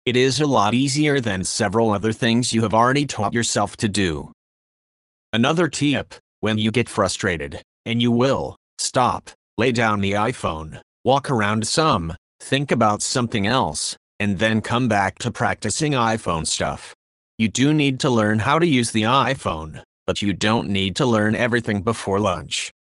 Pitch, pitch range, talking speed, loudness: 115 Hz, 105-125 Hz, 170 wpm, -20 LUFS